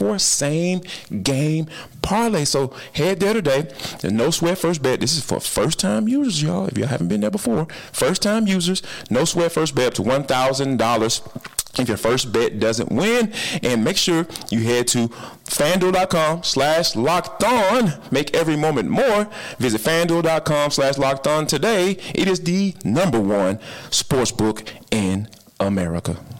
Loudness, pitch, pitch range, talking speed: -20 LUFS, 155 Hz, 120-185 Hz, 155 wpm